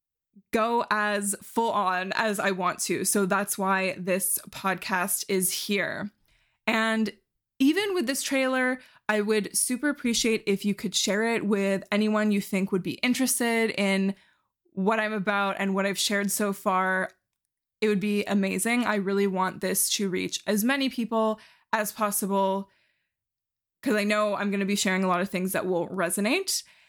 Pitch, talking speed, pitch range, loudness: 205 Hz, 170 wpm, 195-220 Hz, -26 LUFS